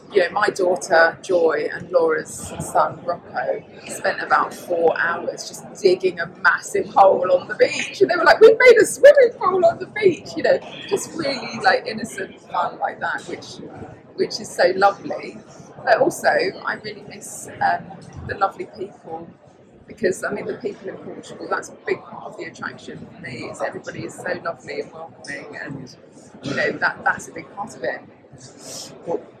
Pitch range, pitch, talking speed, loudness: 305-470 Hz, 385 Hz, 185 wpm, -19 LUFS